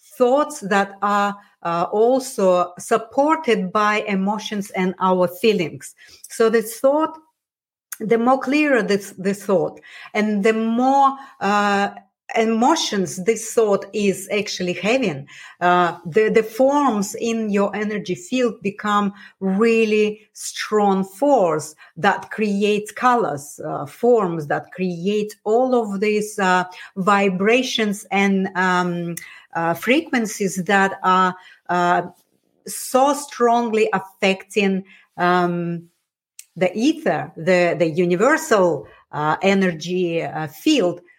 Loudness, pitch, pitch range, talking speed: -19 LUFS, 205 Hz, 185-230 Hz, 110 wpm